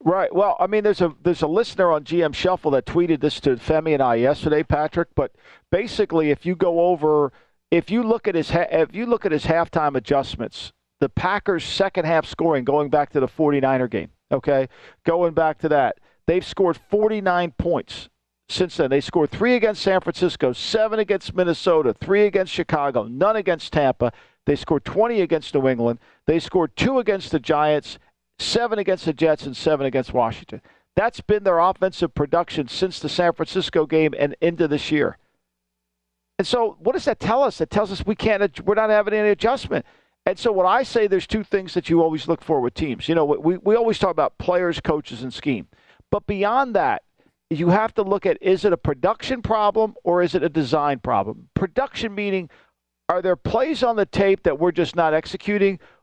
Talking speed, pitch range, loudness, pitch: 200 wpm, 150-200 Hz, -21 LUFS, 170 Hz